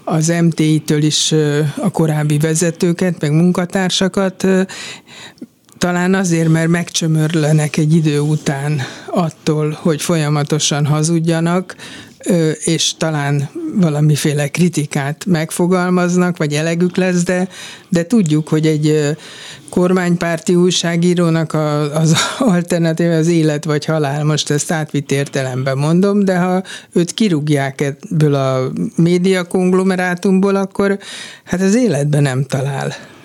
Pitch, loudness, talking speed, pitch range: 165 Hz, -15 LUFS, 105 wpm, 150-180 Hz